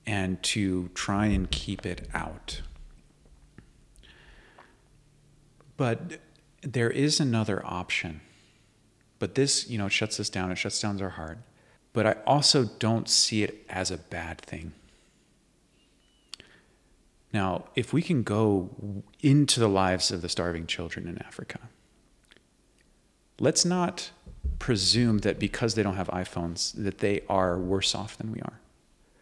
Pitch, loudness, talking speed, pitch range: 105 Hz, -27 LUFS, 135 wpm, 90-120 Hz